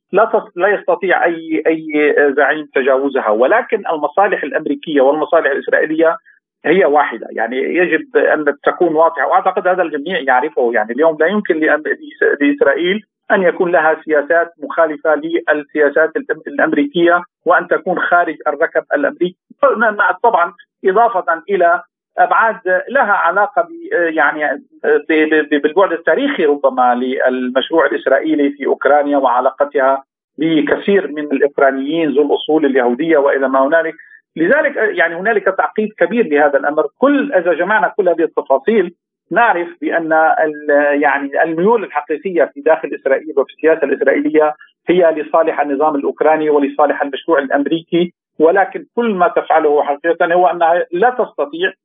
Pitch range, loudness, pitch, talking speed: 145-195 Hz, -14 LUFS, 160 Hz, 125 wpm